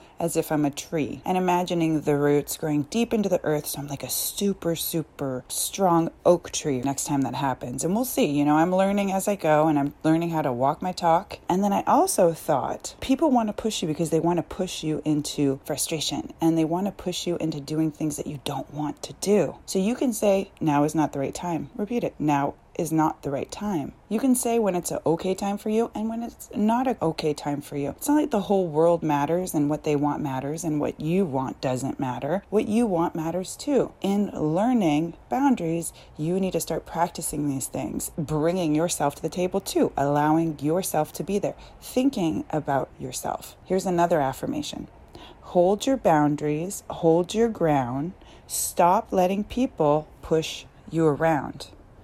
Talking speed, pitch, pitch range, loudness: 205 wpm, 165 Hz, 150-190 Hz, -25 LUFS